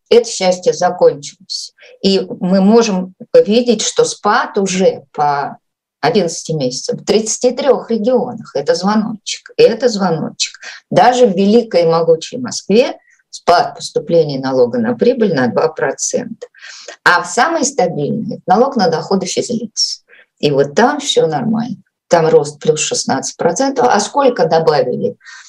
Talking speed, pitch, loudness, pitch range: 125 wpm, 230 Hz, -14 LUFS, 185-250 Hz